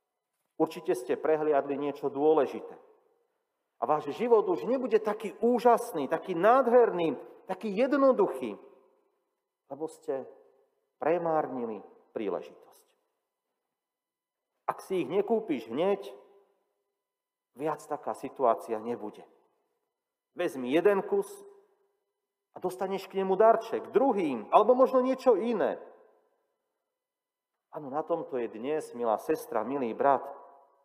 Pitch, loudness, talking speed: 255 Hz, -29 LUFS, 100 wpm